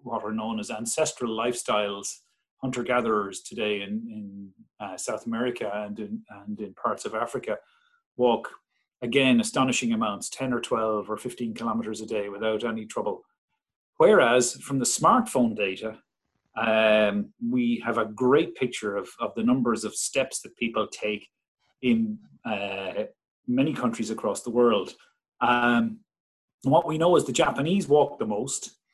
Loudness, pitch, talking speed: -26 LUFS, 120 Hz, 150 wpm